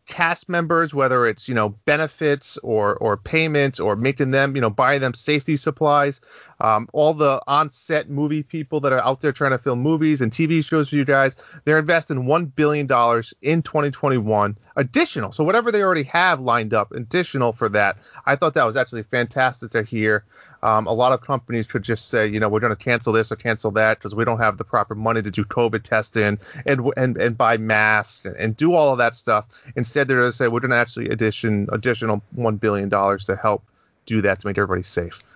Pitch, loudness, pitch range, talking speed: 125 Hz, -20 LUFS, 110-145 Hz, 215 wpm